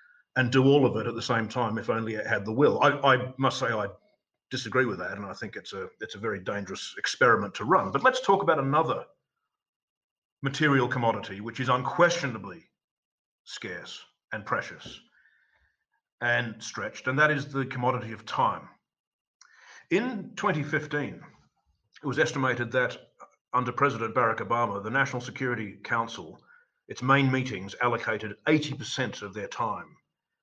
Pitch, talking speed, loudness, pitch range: 130 Hz, 155 wpm, -27 LUFS, 120-150 Hz